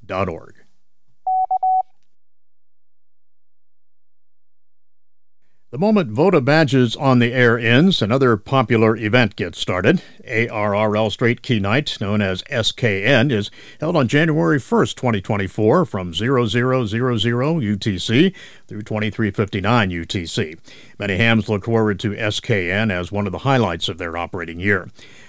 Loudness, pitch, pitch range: -18 LUFS, 110 Hz, 100-125 Hz